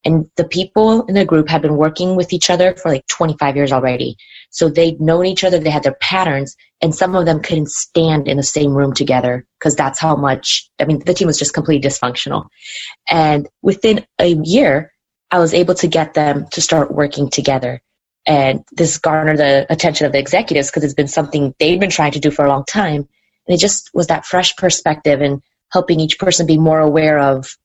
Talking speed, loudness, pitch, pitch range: 215 wpm, -14 LUFS, 155 Hz, 145-175 Hz